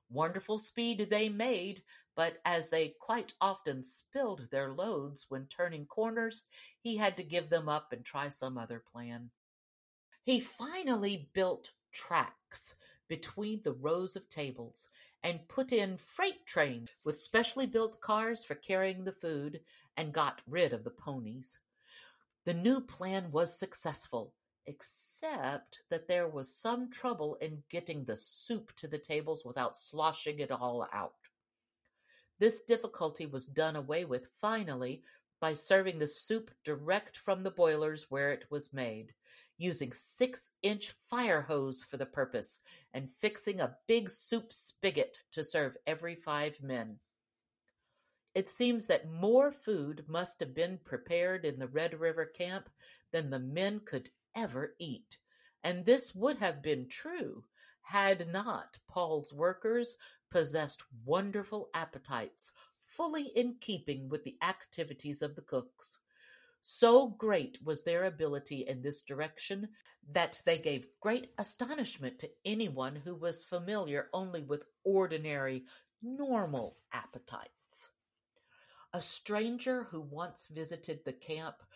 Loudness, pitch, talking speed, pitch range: -36 LUFS, 175 Hz, 135 wpm, 150-220 Hz